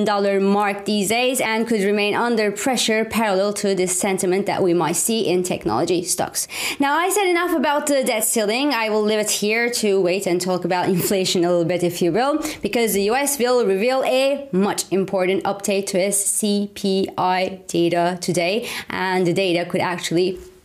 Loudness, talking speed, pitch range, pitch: -19 LUFS, 185 wpm, 185-225 Hz, 200 Hz